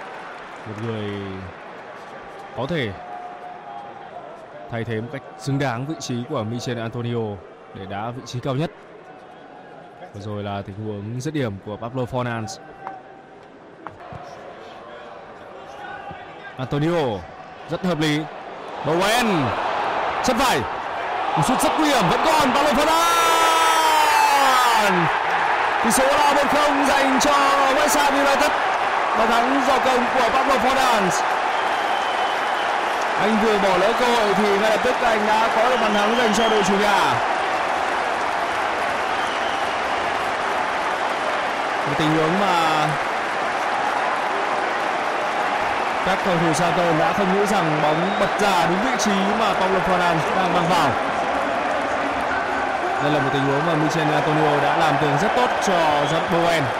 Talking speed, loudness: 130 wpm, -20 LUFS